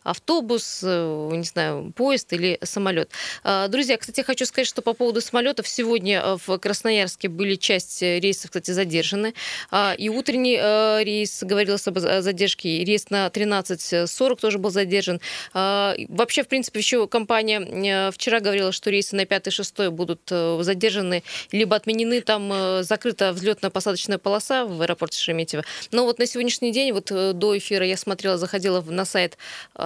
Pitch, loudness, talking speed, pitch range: 200 Hz, -22 LUFS, 140 wpm, 185-225 Hz